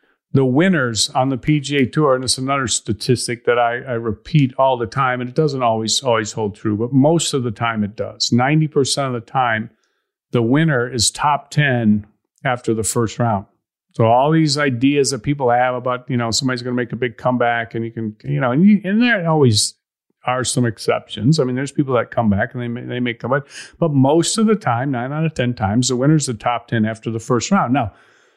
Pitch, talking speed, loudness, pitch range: 125 Hz, 230 wpm, -18 LUFS, 115-140 Hz